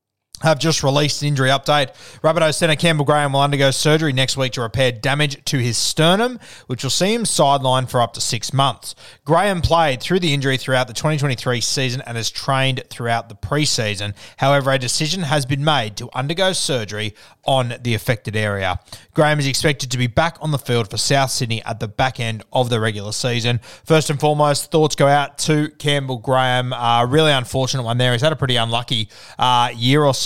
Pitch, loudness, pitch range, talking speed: 130 Hz, -18 LUFS, 120-150 Hz, 200 wpm